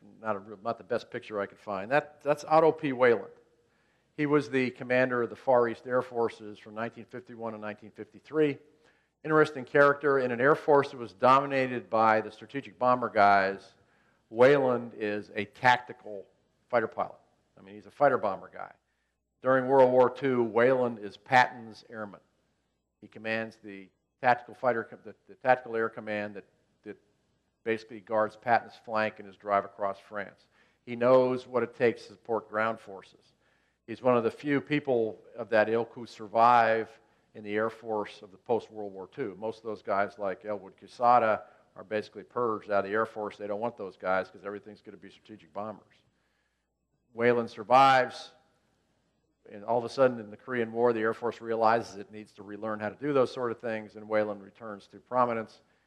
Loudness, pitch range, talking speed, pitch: -28 LUFS, 105-125 Hz, 185 wpm, 110 Hz